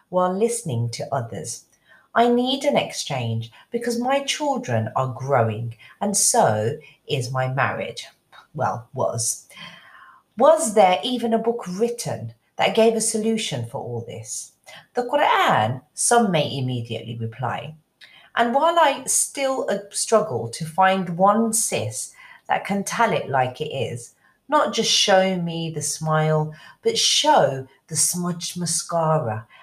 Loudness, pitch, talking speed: -21 LUFS, 170 Hz, 135 wpm